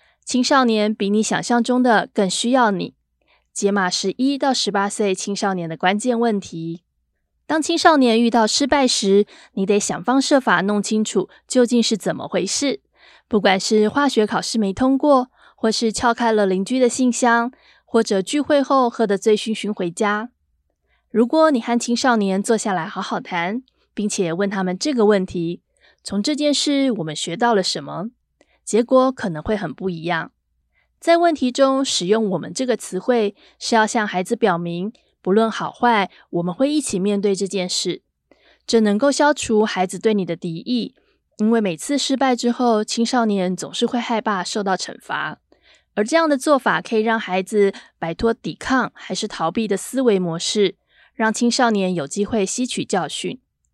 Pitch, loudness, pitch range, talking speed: 220 Hz, -19 LUFS, 195-250 Hz, 255 characters per minute